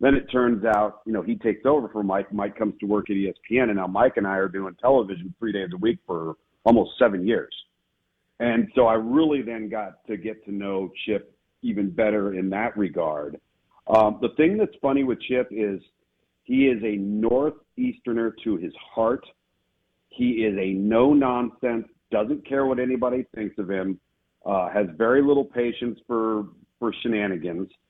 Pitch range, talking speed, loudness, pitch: 100-125 Hz, 180 wpm, -24 LUFS, 110 Hz